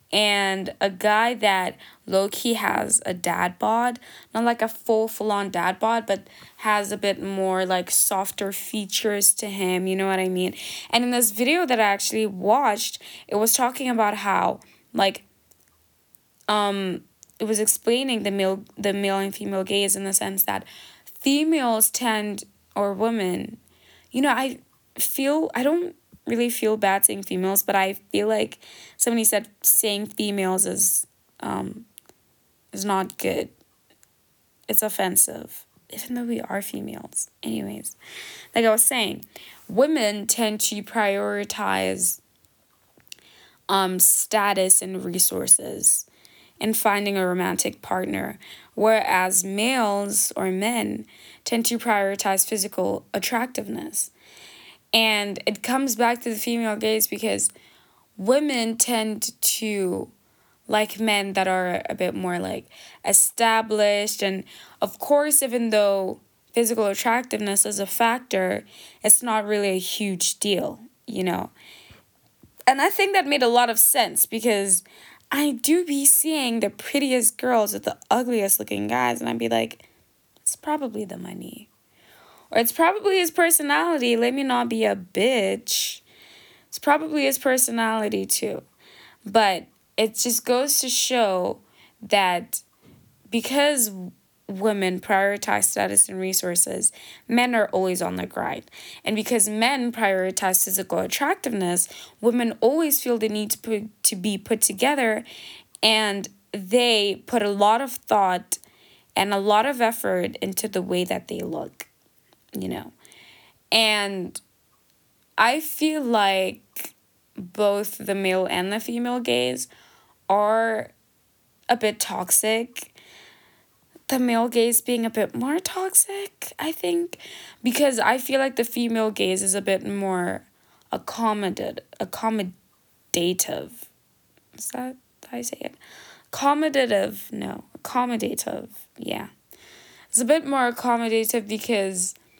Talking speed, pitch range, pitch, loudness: 135 wpm, 195-240 Hz, 215 Hz, -22 LUFS